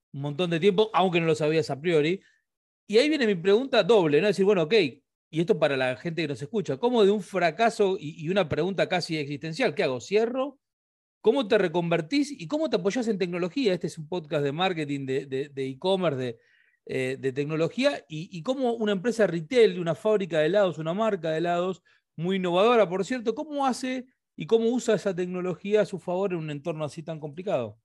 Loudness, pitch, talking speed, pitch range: -26 LUFS, 185 Hz, 215 wpm, 160-215 Hz